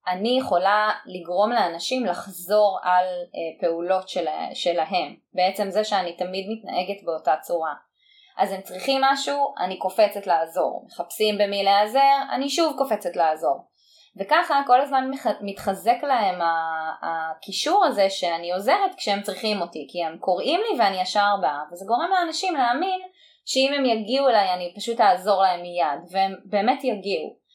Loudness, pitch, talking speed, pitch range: -23 LUFS, 200 Hz, 140 wpm, 180-265 Hz